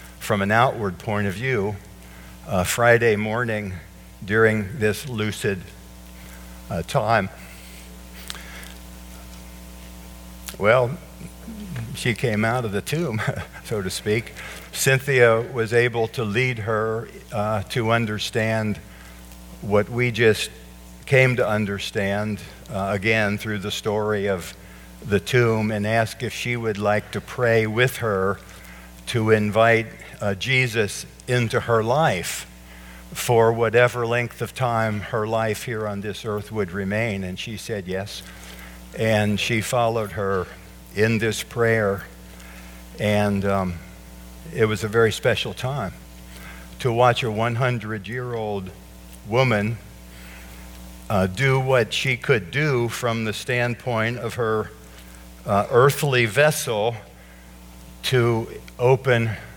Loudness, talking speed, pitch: -22 LUFS, 120 wpm, 105 Hz